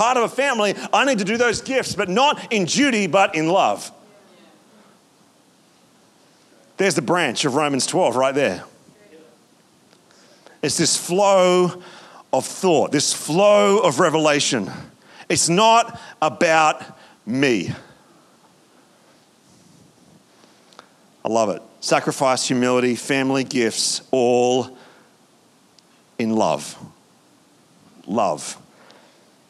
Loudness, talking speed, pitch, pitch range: -19 LUFS, 100 wpm, 170 Hz, 135-200 Hz